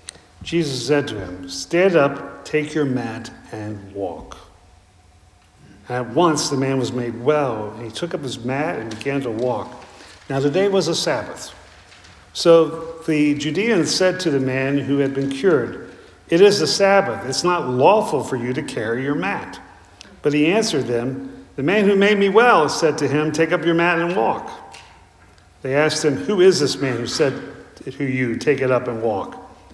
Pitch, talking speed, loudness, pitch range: 135 Hz, 190 wpm, -19 LUFS, 110-165 Hz